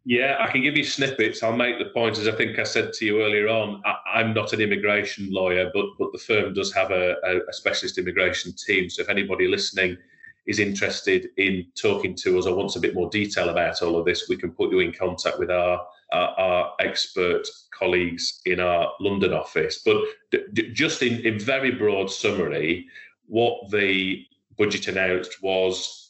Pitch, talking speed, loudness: 115 Hz, 200 wpm, -23 LUFS